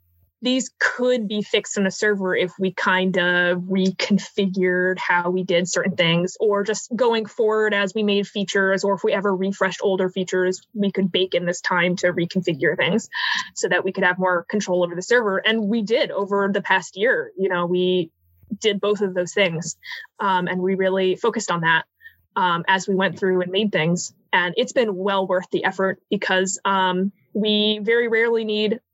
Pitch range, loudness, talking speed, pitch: 180-210 Hz, -21 LUFS, 195 wpm, 190 Hz